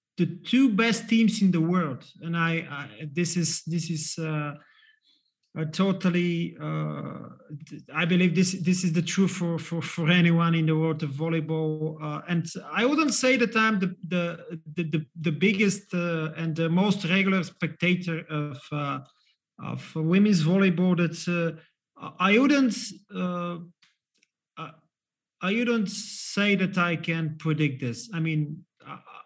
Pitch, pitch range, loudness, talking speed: 170 Hz, 160-190 Hz, -26 LUFS, 155 wpm